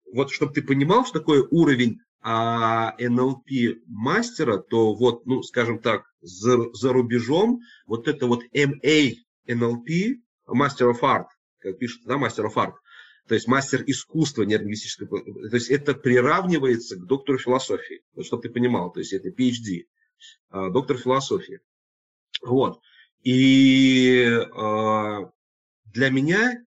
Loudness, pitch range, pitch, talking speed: -22 LUFS, 115-145 Hz, 125 Hz, 135 wpm